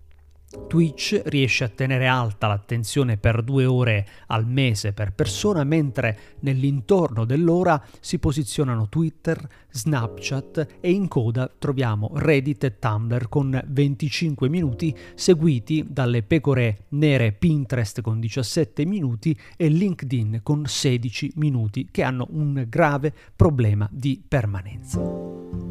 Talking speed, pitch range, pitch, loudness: 115 wpm, 115-150 Hz, 130 Hz, -23 LUFS